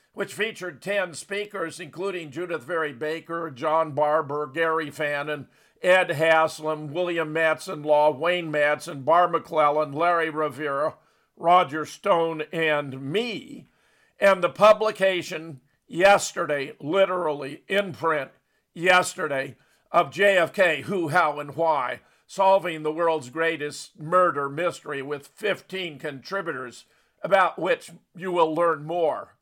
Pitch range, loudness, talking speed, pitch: 150-180 Hz, -24 LUFS, 115 wpm, 165 Hz